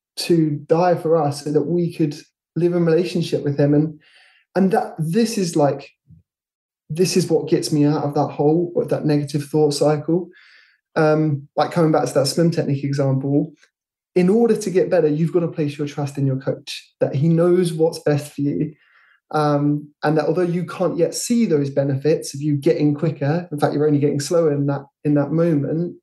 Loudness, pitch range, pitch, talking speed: -19 LUFS, 145-170 Hz, 155 Hz, 205 wpm